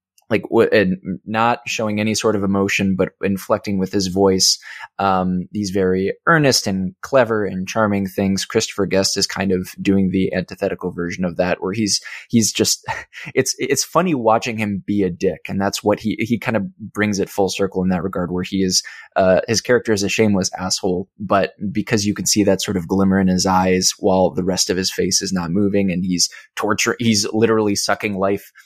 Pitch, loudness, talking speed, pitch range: 100 Hz, -18 LUFS, 205 wpm, 95-105 Hz